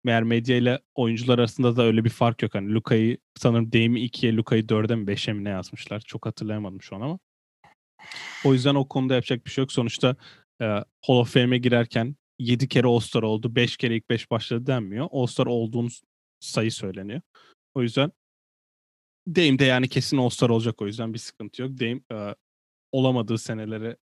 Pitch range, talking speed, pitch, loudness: 115-130 Hz, 185 wpm, 120 Hz, -24 LUFS